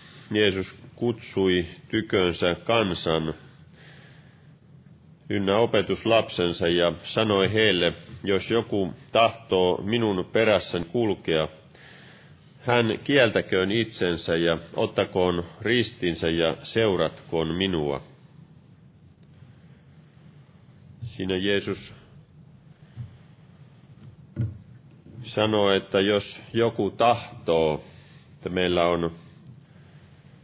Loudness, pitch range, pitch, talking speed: -24 LUFS, 90-140 Hz, 110 Hz, 65 wpm